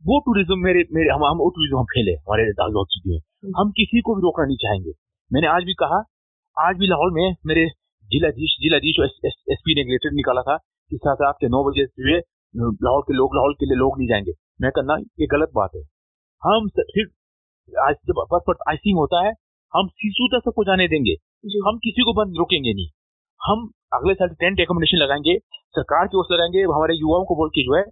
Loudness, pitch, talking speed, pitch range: -20 LUFS, 165 Hz, 205 wpm, 135-190 Hz